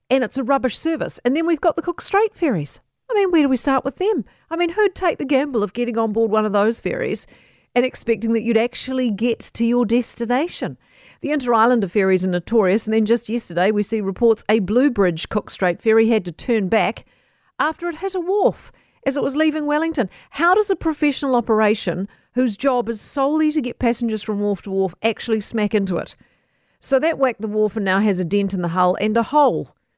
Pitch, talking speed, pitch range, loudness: 235 Hz, 220 wpm, 215-290 Hz, -20 LUFS